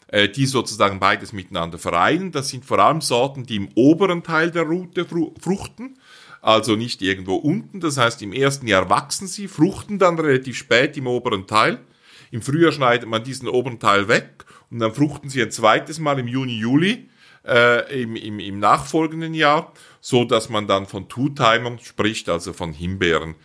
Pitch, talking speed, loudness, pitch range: 125 Hz, 180 wpm, -20 LUFS, 105-160 Hz